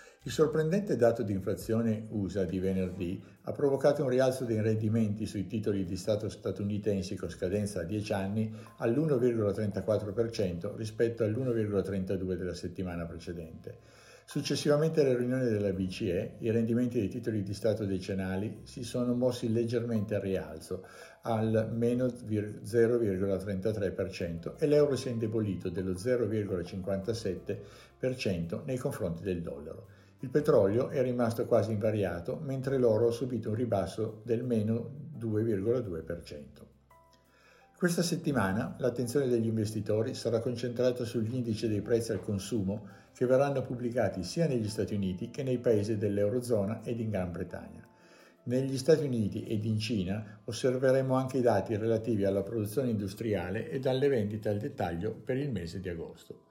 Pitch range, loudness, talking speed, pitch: 100-125 Hz, -32 LUFS, 135 wpm, 110 Hz